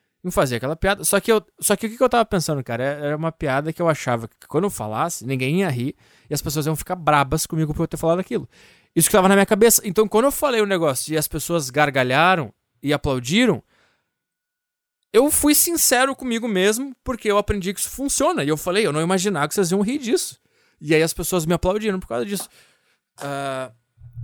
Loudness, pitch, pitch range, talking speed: -20 LUFS, 180 Hz, 150-215 Hz, 225 wpm